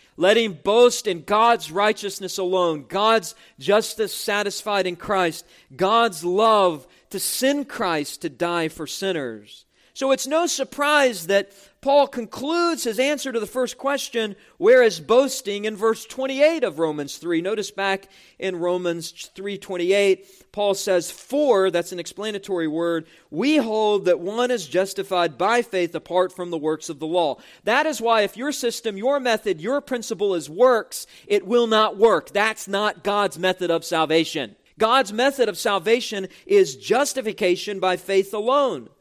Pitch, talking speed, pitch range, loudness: 205 Hz, 155 wpm, 180-240 Hz, -21 LUFS